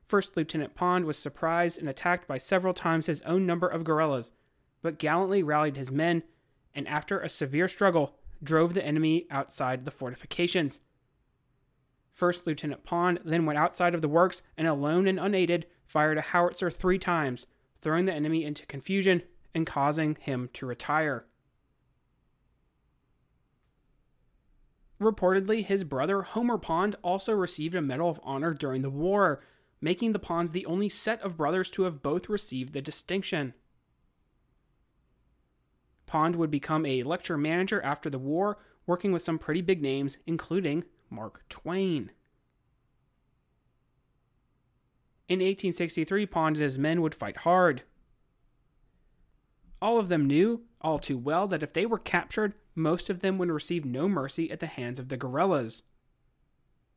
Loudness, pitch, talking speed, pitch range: -29 LUFS, 165 Hz, 145 wpm, 140-180 Hz